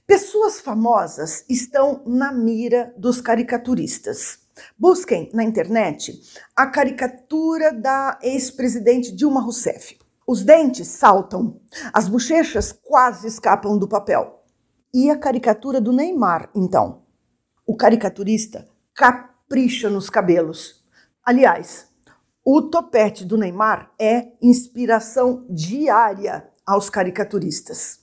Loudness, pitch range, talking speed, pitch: -18 LUFS, 215-265 Hz, 100 wpm, 240 Hz